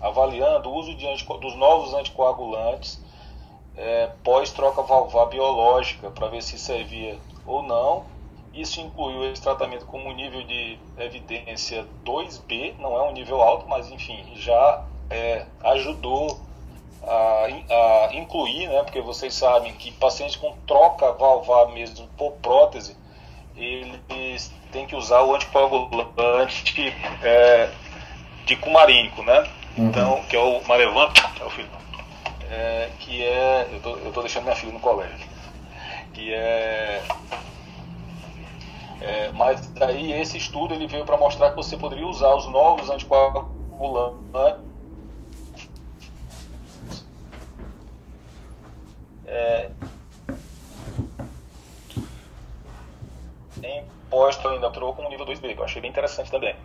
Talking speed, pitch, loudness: 125 wpm, 120 Hz, -21 LUFS